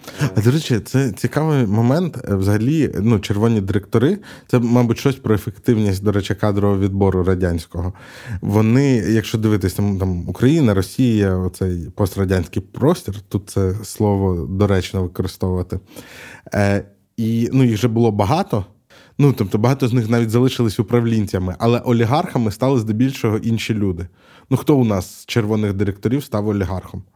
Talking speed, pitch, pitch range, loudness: 140 wpm, 110 Hz, 100-120 Hz, -18 LUFS